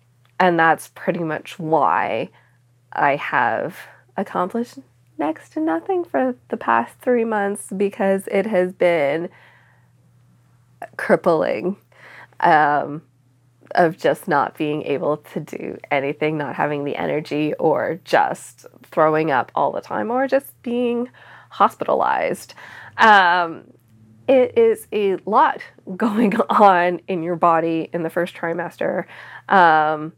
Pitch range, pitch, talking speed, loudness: 150-220 Hz, 170 Hz, 120 wpm, -19 LUFS